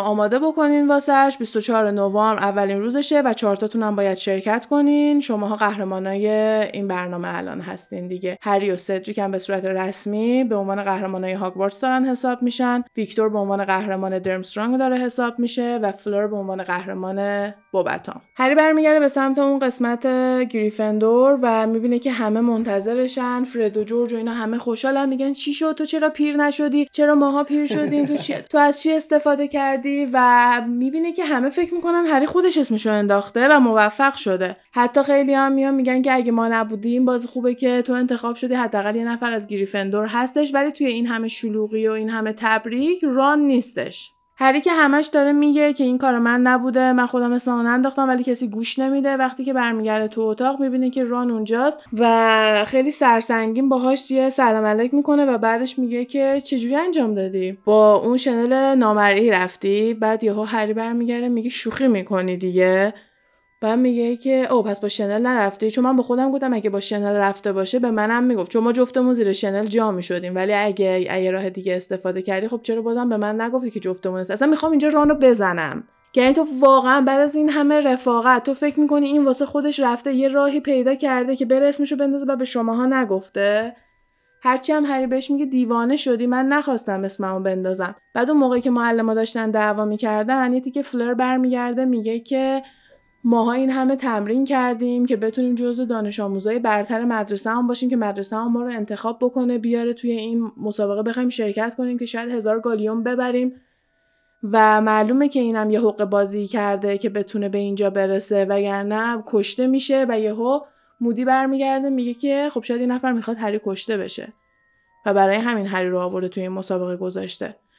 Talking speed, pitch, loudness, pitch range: 185 wpm, 235 Hz, -19 LUFS, 210-265 Hz